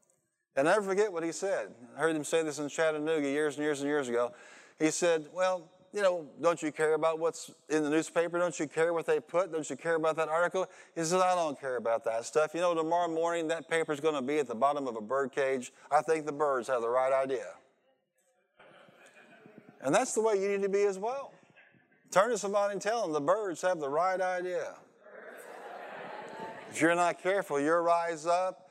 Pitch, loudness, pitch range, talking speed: 165 Hz, -31 LUFS, 150-180 Hz, 220 wpm